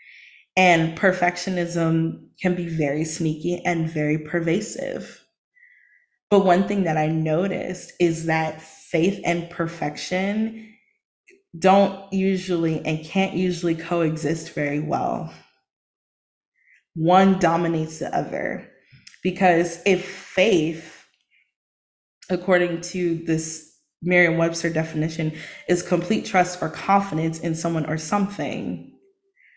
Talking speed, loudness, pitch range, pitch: 100 wpm, -22 LUFS, 160-185 Hz, 170 Hz